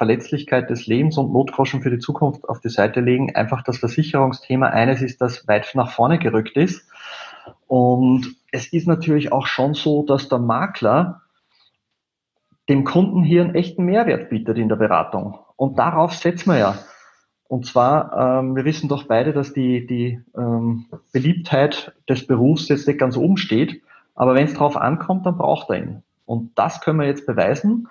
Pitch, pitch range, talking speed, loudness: 135 Hz, 125-155 Hz, 175 wpm, -19 LUFS